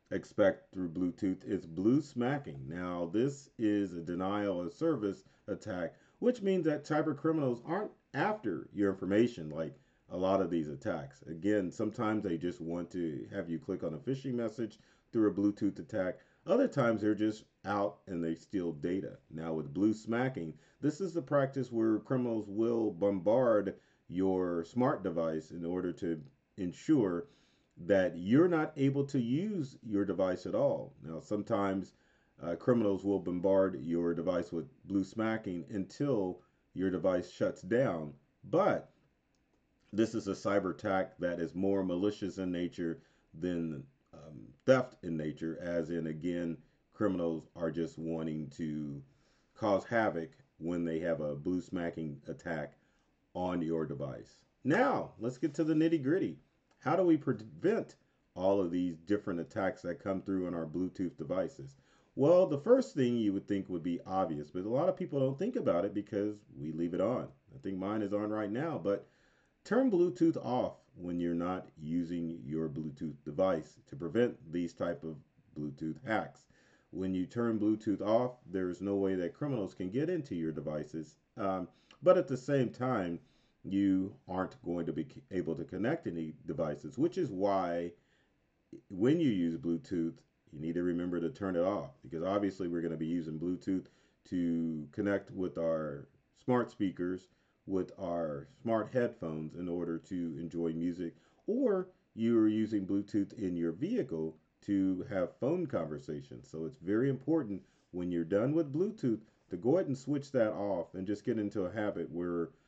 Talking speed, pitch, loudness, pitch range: 165 wpm, 95 Hz, -34 LUFS, 85-115 Hz